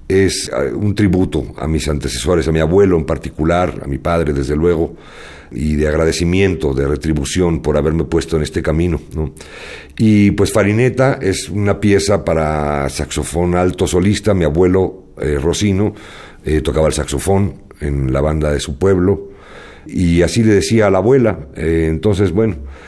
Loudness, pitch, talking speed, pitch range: -15 LUFS, 85 Hz, 165 wpm, 75-100 Hz